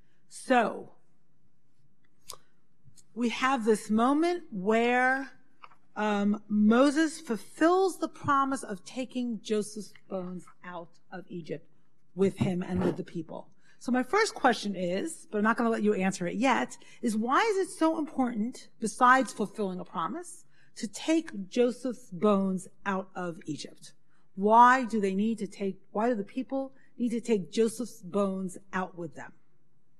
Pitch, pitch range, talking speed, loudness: 215 Hz, 185-255 Hz, 150 wpm, -28 LUFS